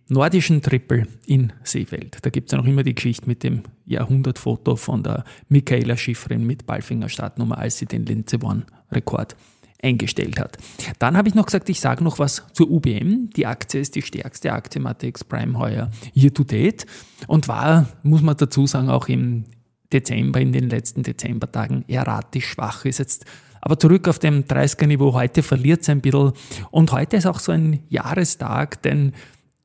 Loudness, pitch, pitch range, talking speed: -20 LUFS, 135 Hz, 120-150 Hz, 180 wpm